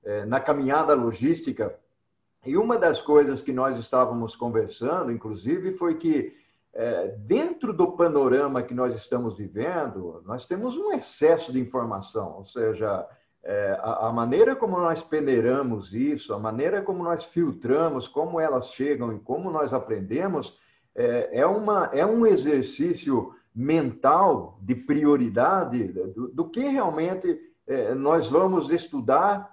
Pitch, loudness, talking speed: 165 Hz, -25 LUFS, 125 wpm